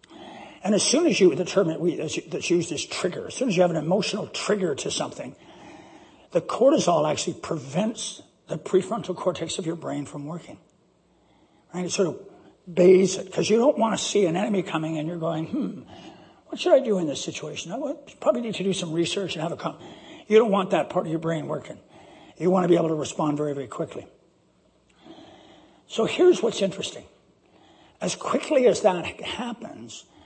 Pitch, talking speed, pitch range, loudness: 185 Hz, 200 wpm, 165-210 Hz, -24 LUFS